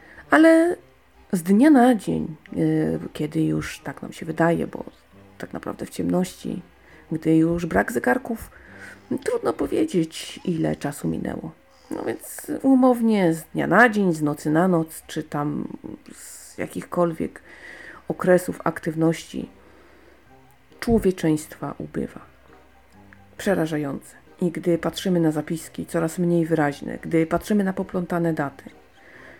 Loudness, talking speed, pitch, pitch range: -23 LUFS, 120 wpm, 165 Hz, 150-190 Hz